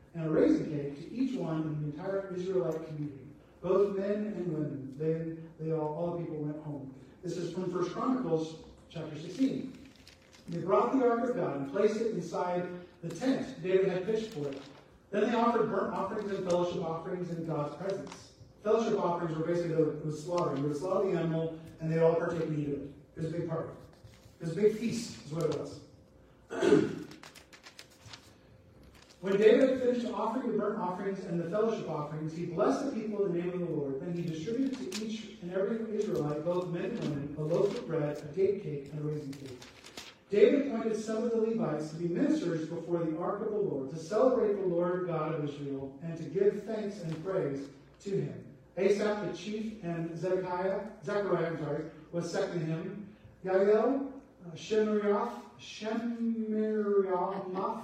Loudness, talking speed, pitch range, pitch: -32 LUFS, 185 wpm, 160-210 Hz, 180 Hz